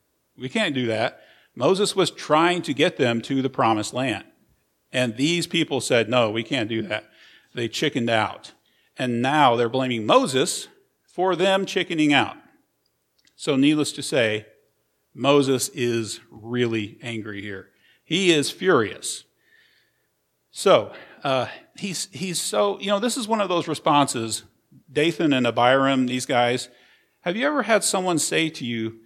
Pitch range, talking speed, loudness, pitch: 115-170 Hz, 150 wpm, -22 LUFS, 135 Hz